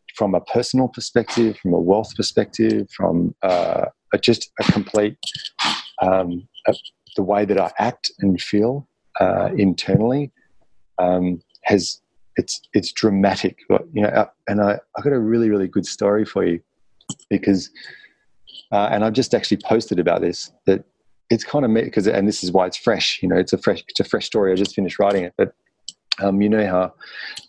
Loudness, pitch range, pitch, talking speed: -20 LUFS, 95-110 Hz, 100 Hz, 185 wpm